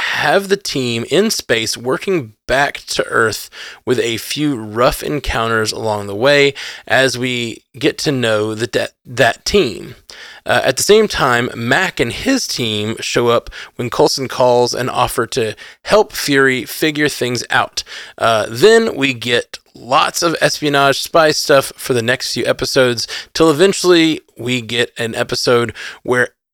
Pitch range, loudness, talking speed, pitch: 120-155 Hz, -15 LUFS, 155 wpm, 130 Hz